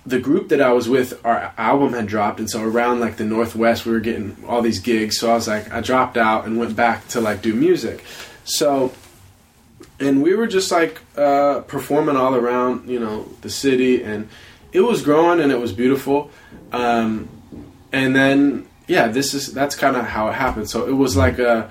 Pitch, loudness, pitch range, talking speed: 120 Hz, -18 LUFS, 110-135 Hz, 205 wpm